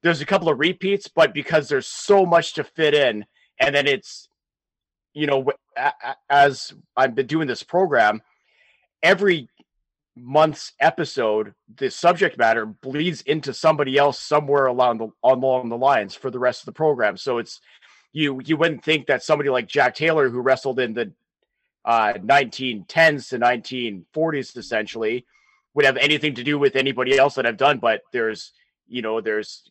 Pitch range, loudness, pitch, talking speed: 125-155 Hz, -20 LUFS, 140 Hz, 165 wpm